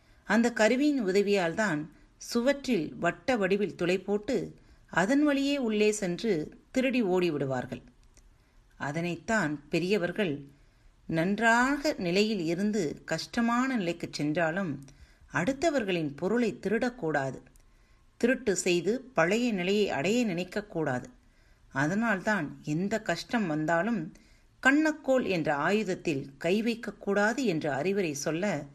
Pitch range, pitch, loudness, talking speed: 155-225 Hz, 190 Hz, -29 LUFS, 90 wpm